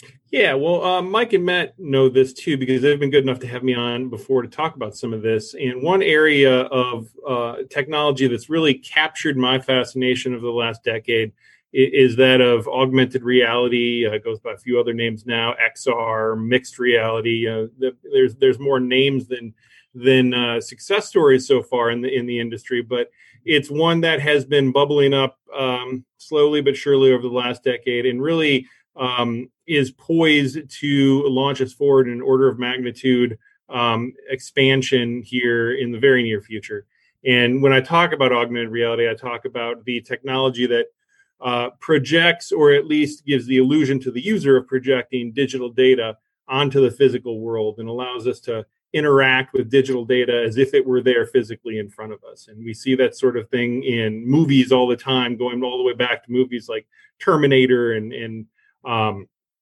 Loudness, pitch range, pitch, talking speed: -19 LUFS, 120-140 Hz, 130 Hz, 185 wpm